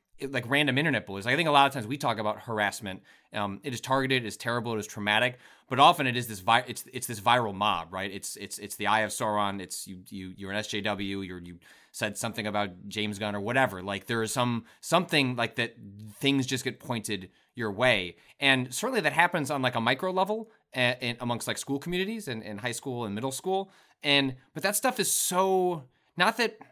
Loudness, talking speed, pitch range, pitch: -28 LUFS, 225 wpm, 105-140 Hz, 120 Hz